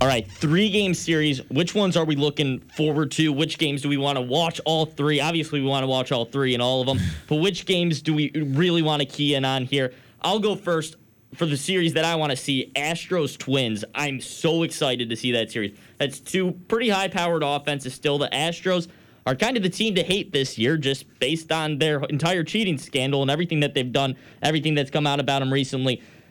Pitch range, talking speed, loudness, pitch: 135-165 Hz, 230 wpm, -23 LUFS, 150 Hz